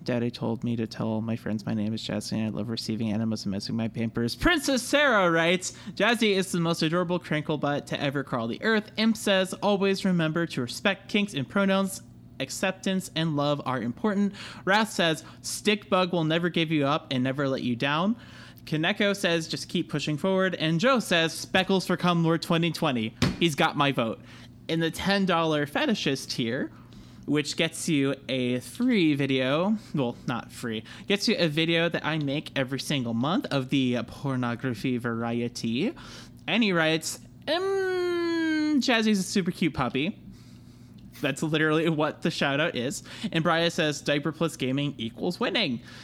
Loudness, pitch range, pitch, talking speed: -26 LUFS, 130-190 Hz, 160 Hz, 175 wpm